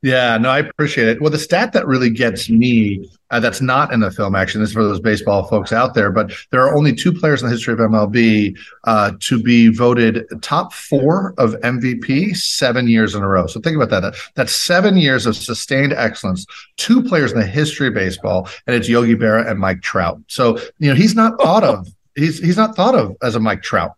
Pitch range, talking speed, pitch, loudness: 110-150 Hz, 225 wpm, 120 Hz, -15 LUFS